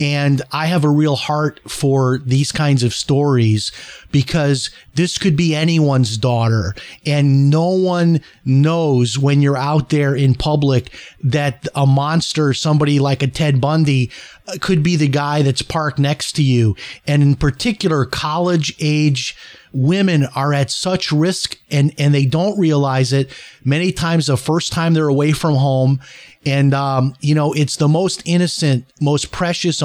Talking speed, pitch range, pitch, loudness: 155 wpm, 135-160 Hz, 145 Hz, -16 LUFS